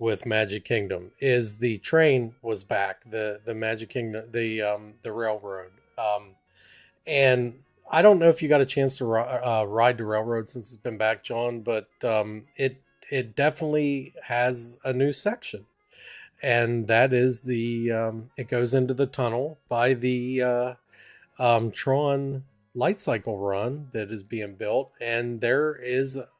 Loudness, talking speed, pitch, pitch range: -26 LUFS, 160 wpm, 120 Hz, 110-130 Hz